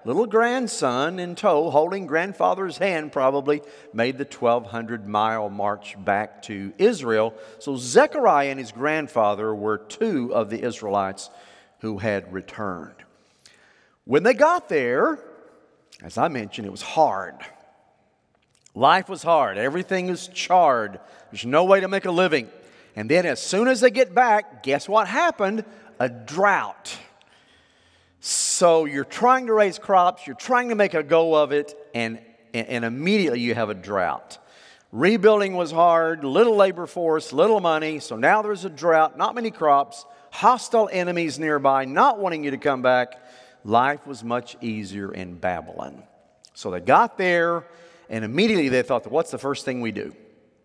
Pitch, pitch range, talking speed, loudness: 150 Hz, 115-190 Hz, 155 wpm, -22 LUFS